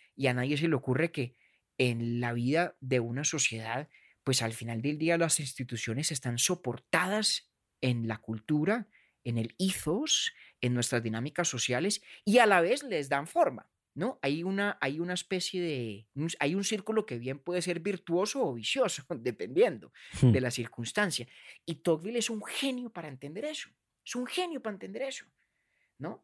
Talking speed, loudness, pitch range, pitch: 170 wpm, -31 LUFS, 125-195 Hz, 150 Hz